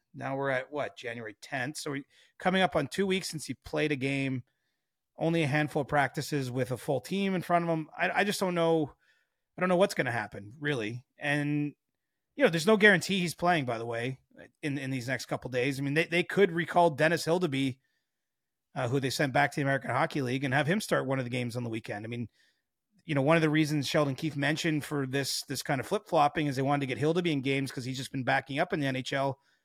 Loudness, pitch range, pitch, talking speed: -30 LUFS, 135-165 Hz, 145 Hz, 255 wpm